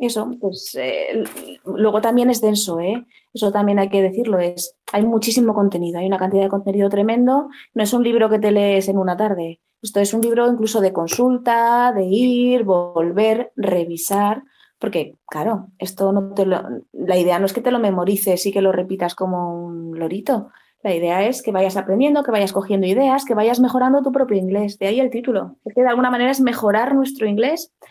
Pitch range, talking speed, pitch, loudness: 190-240 Hz, 200 wpm, 210 Hz, -18 LUFS